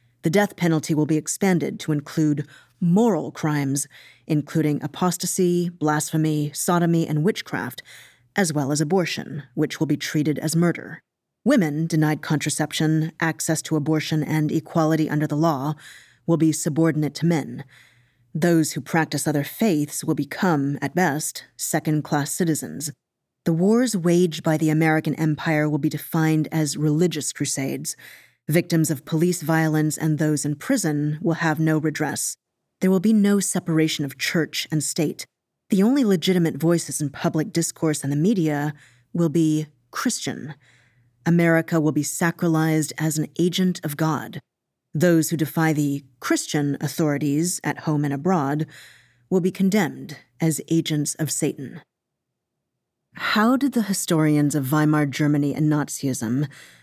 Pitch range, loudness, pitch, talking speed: 150-170 Hz, -22 LUFS, 155 Hz, 145 wpm